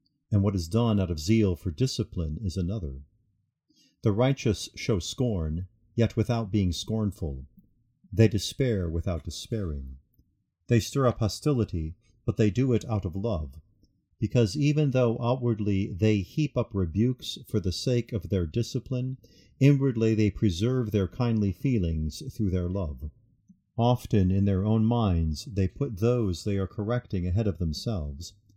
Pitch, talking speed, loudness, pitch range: 105 Hz, 150 wpm, -27 LUFS, 95-120 Hz